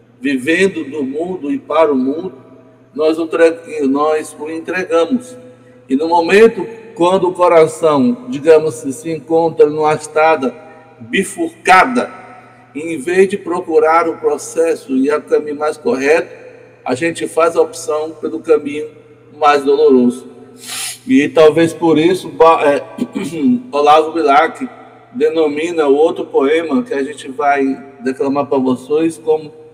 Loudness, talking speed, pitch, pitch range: -14 LUFS, 130 wpm, 160 Hz, 150-185 Hz